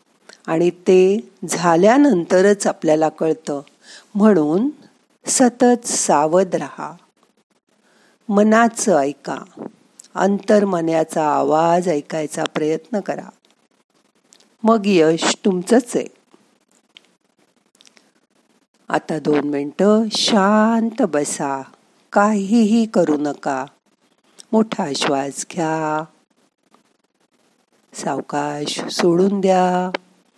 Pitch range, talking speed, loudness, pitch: 155-215 Hz, 70 wpm, -17 LUFS, 185 Hz